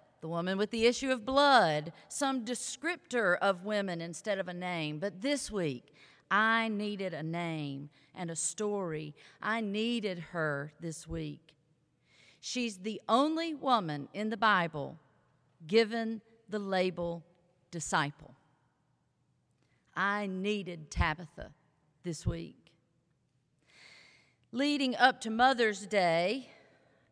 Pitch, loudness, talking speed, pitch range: 185 Hz, -32 LUFS, 115 wpm, 155-225 Hz